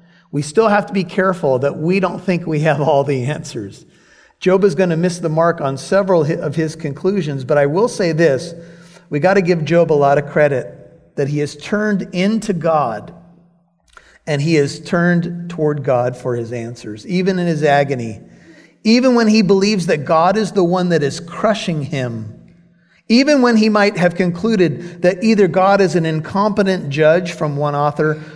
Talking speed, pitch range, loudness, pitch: 190 wpm, 150-190 Hz, -16 LUFS, 170 Hz